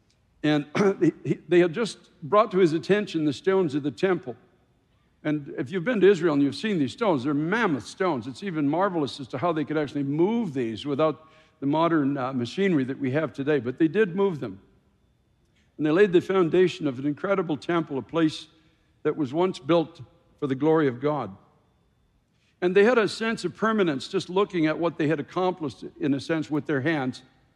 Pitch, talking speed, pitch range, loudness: 155 Hz, 200 wpm, 140-185 Hz, -25 LUFS